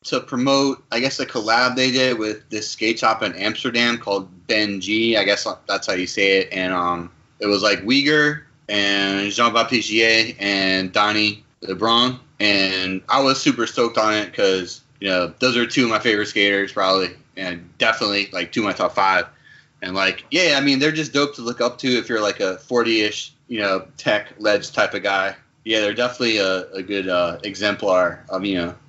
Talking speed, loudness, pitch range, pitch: 200 wpm, -19 LUFS, 100-125 Hz, 105 Hz